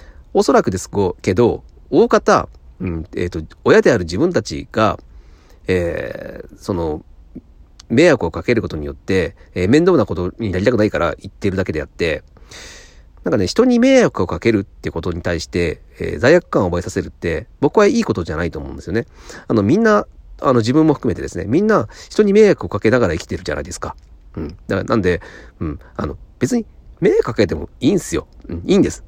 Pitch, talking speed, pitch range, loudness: 90 Hz, 395 characters per minute, 80-120 Hz, -17 LUFS